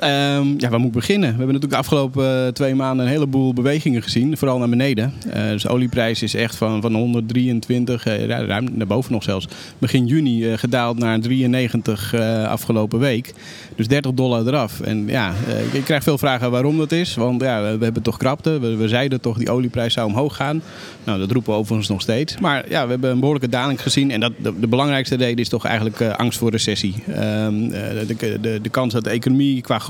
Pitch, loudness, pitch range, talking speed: 120 Hz, -19 LUFS, 115-135 Hz, 195 wpm